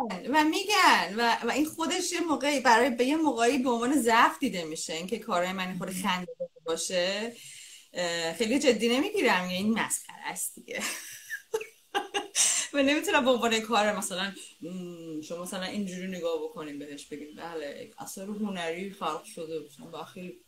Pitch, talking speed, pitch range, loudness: 220 Hz, 150 wpm, 175-280 Hz, -28 LUFS